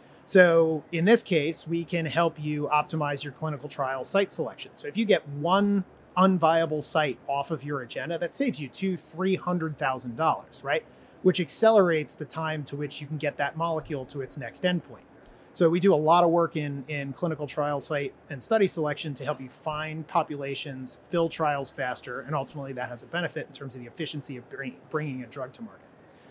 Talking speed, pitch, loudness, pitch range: 200 wpm, 155 Hz, -27 LUFS, 140-170 Hz